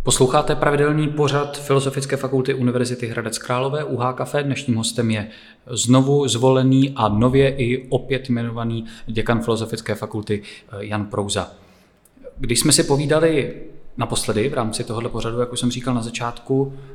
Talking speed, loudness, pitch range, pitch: 140 wpm, -20 LUFS, 115-135 Hz, 125 Hz